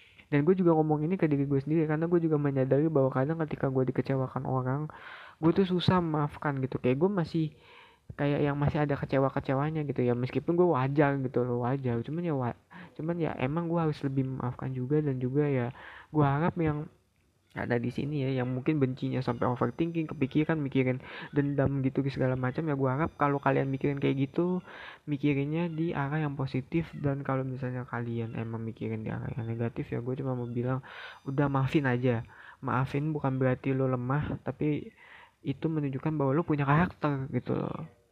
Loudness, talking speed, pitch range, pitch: -30 LUFS, 185 wpm, 130-155 Hz, 140 Hz